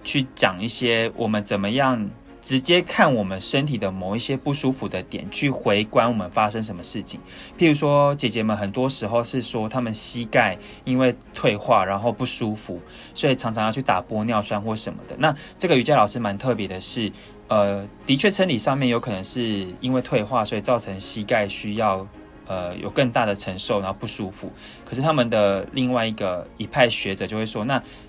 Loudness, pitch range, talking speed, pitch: -22 LUFS, 100-130 Hz, 295 characters per minute, 110 Hz